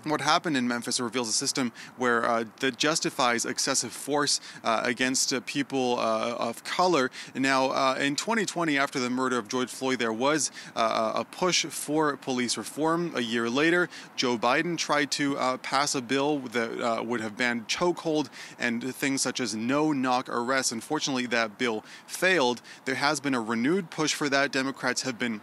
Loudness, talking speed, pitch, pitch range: -27 LUFS, 180 wpm, 130 Hz, 120-150 Hz